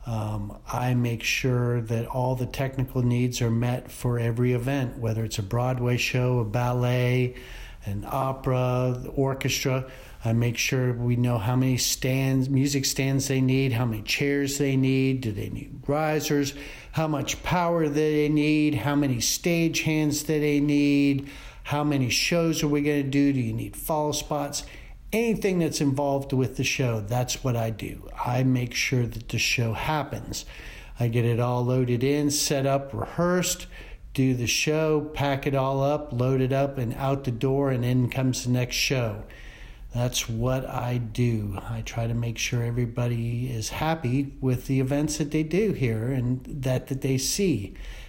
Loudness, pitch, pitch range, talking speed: -25 LUFS, 130 Hz, 120-145 Hz, 175 wpm